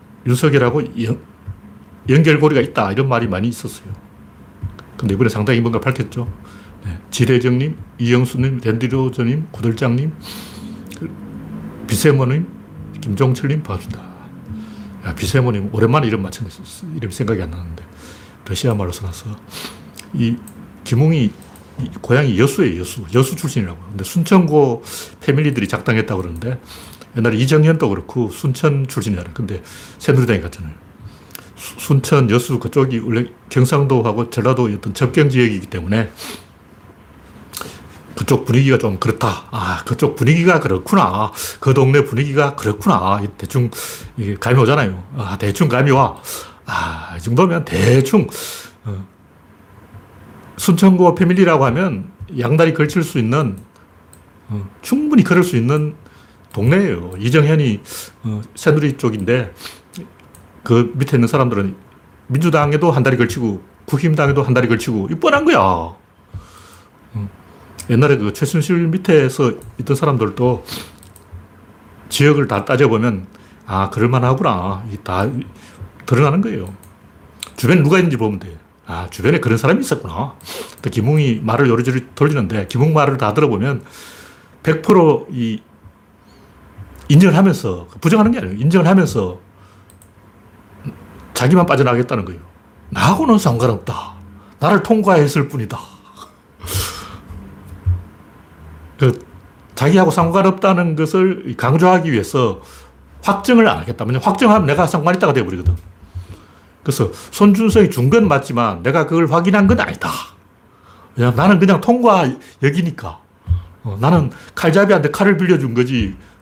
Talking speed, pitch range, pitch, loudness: 290 characters per minute, 100-150 Hz, 120 Hz, -16 LUFS